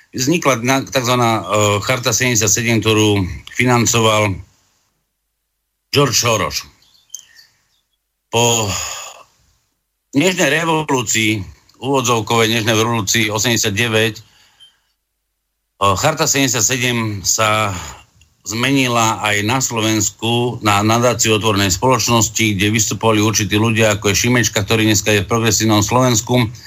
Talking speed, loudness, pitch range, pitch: 90 wpm, -15 LUFS, 105-120 Hz, 110 Hz